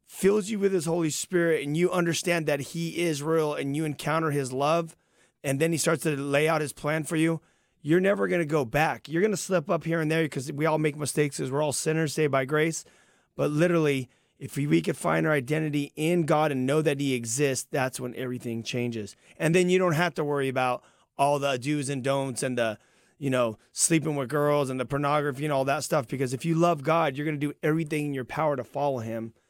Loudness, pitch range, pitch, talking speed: -27 LUFS, 135-165 Hz, 150 Hz, 240 wpm